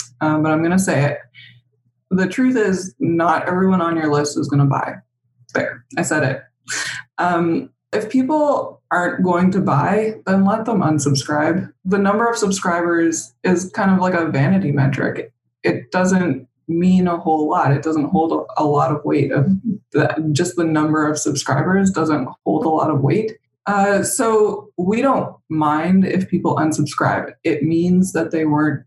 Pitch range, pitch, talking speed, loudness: 150-190 Hz, 170 Hz, 175 wpm, -18 LUFS